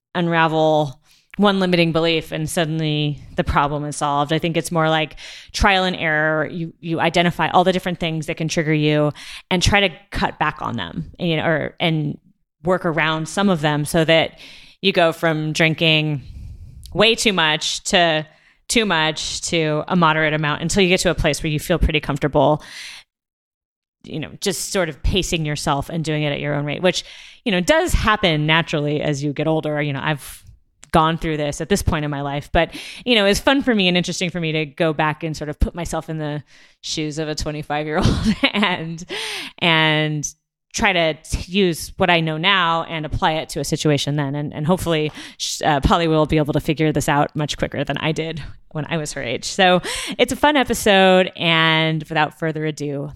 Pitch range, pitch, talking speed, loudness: 150-175 Hz, 160 Hz, 205 wpm, -19 LUFS